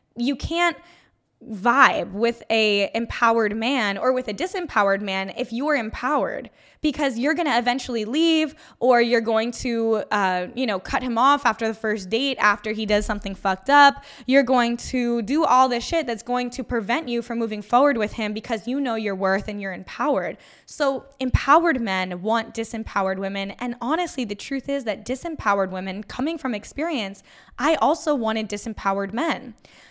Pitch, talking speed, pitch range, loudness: 235 Hz, 175 wpm, 210-275 Hz, -22 LUFS